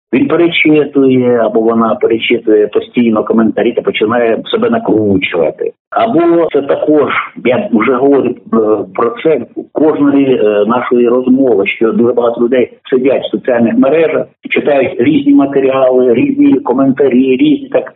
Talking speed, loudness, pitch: 125 wpm, -10 LUFS, 135 Hz